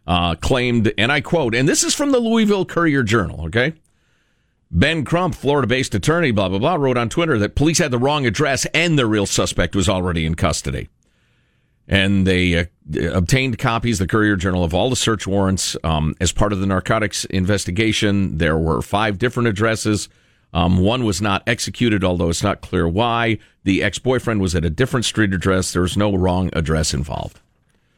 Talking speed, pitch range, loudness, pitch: 195 wpm, 90-125 Hz, -18 LUFS, 105 Hz